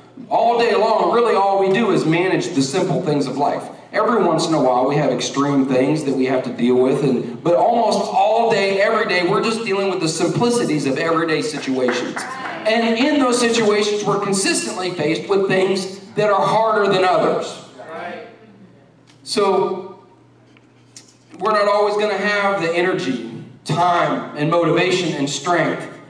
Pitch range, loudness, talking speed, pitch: 150-210 Hz, -18 LUFS, 170 wpm, 185 Hz